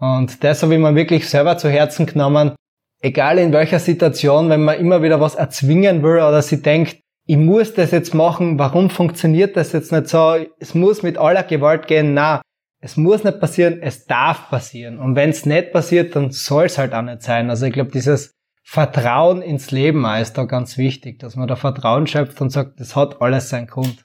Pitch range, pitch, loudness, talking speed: 135-165 Hz, 150 Hz, -16 LUFS, 210 wpm